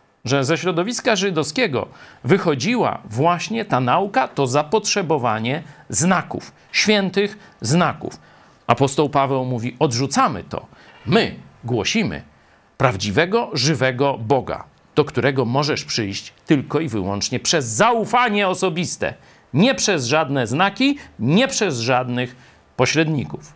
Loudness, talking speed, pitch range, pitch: -19 LUFS, 105 wpm, 125-185 Hz, 150 Hz